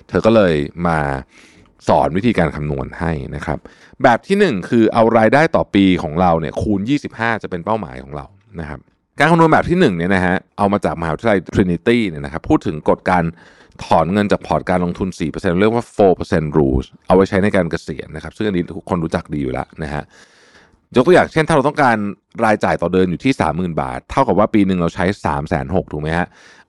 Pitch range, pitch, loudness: 80-105 Hz, 90 Hz, -16 LUFS